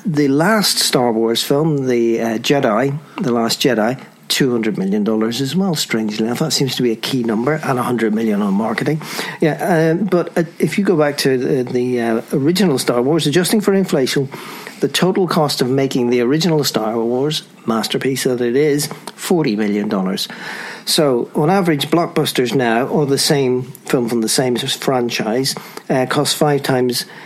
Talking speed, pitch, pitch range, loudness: 185 wpm, 140 Hz, 120-170 Hz, -16 LUFS